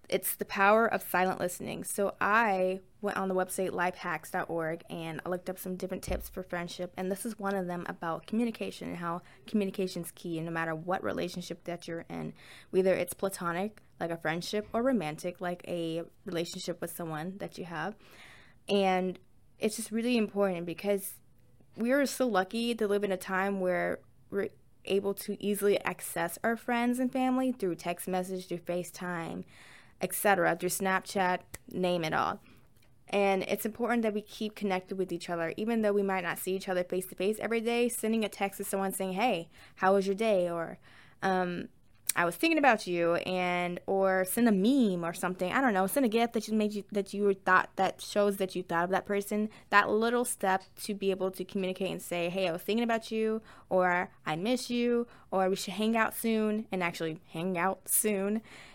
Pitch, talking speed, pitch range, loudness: 190 Hz, 200 wpm, 175-210 Hz, -31 LUFS